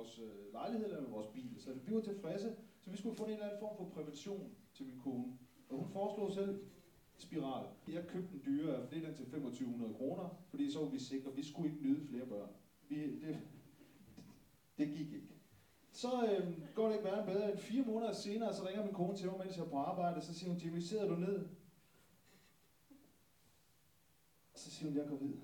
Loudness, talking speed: -43 LUFS, 210 wpm